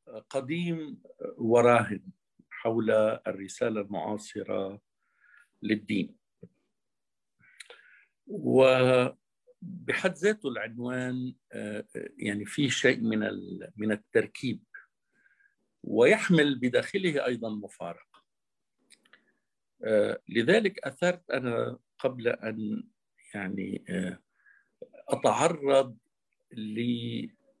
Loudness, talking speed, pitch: -28 LUFS, 60 wpm, 130 Hz